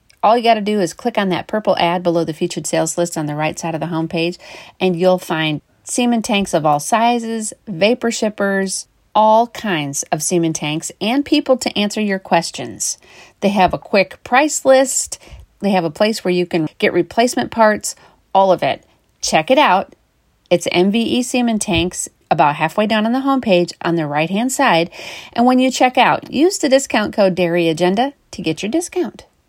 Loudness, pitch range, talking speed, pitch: -16 LUFS, 170-235 Hz, 195 wpm, 195 Hz